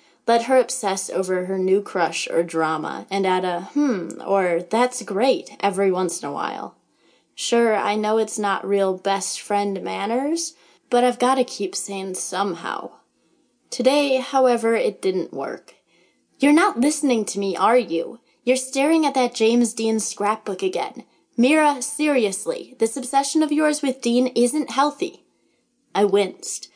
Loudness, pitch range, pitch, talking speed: -21 LUFS, 195-265 Hz, 230 Hz, 155 wpm